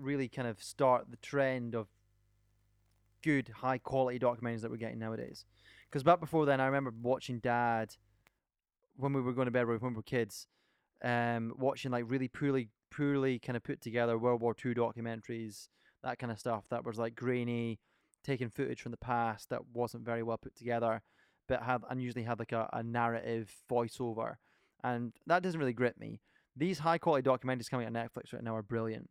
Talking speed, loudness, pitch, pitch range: 190 wpm, -35 LUFS, 120 Hz, 115-130 Hz